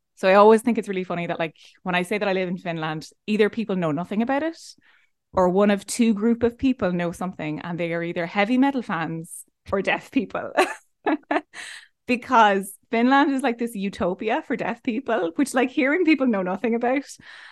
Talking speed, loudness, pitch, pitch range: 200 wpm, -23 LUFS, 210 Hz, 180-250 Hz